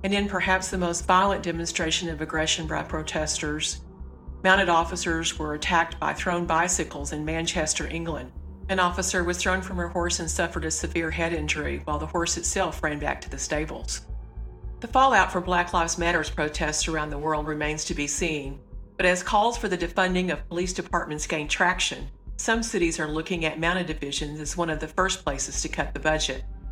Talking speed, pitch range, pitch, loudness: 190 wpm, 150-180 Hz, 165 Hz, -25 LUFS